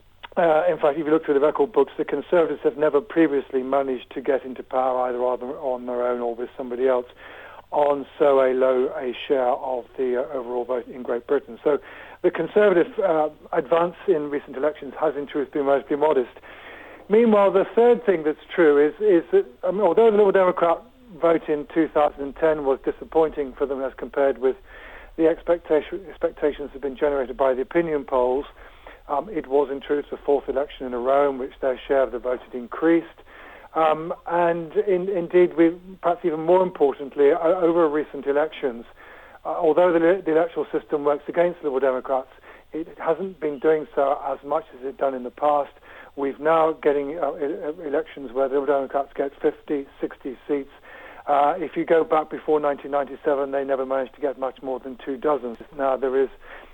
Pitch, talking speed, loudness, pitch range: 145 Hz, 190 wpm, -22 LUFS, 135-165 Hz